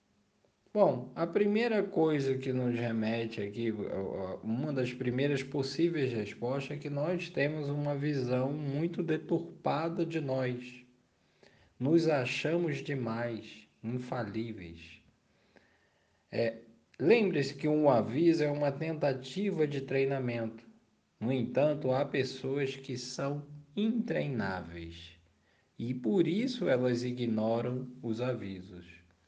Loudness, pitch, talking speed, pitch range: -32 LUFS, 130 Hz, 105 wpm, 115-150 Hz